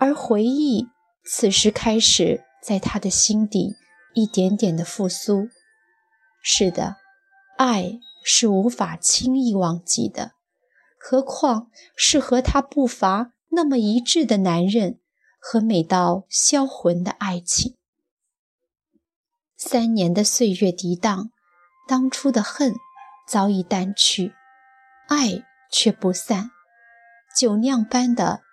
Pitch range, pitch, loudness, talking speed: 195-260 Hz, 225 Hz, -20 LUFS, 155 characters per minute